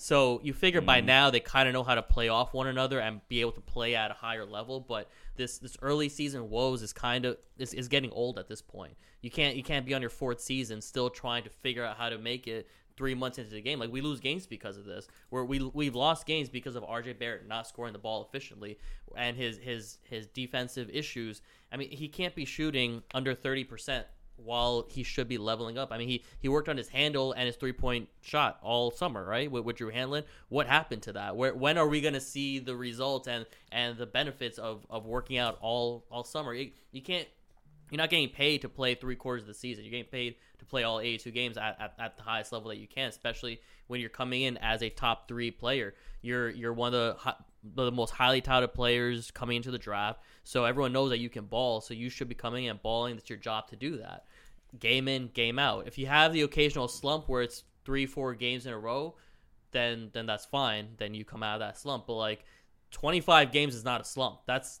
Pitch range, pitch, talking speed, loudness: 115-135 Hz, 125 Hz, 240 wpm, -32 LUFS